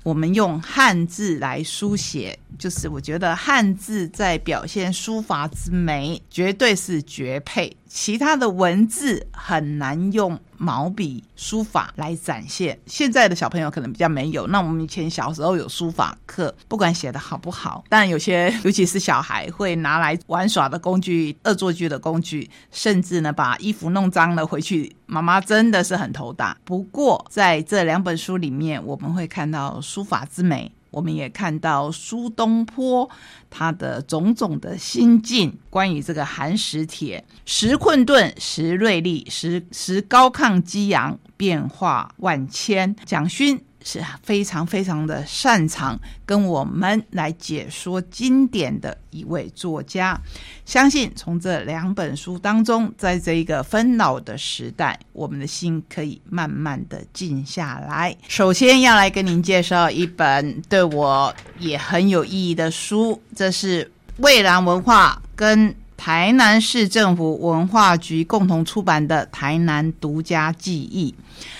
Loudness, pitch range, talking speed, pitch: -20 LUFS, 160-205 Hz, 225 characters per minute, 175 Hz